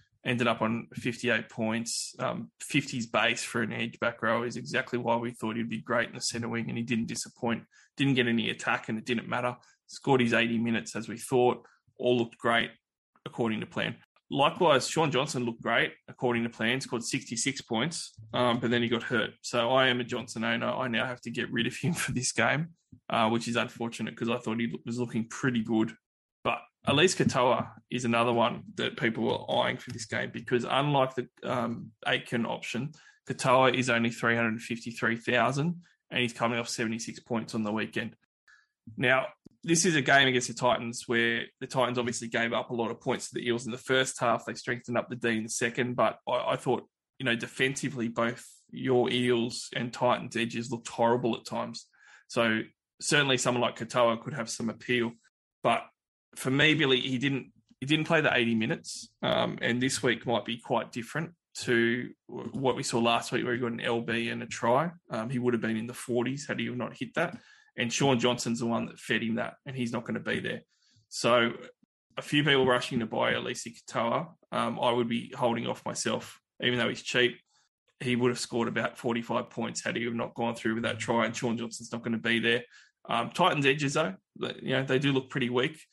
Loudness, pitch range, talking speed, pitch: -29 LUFS, 115-130 Hz, 215 wpm, 120 Hz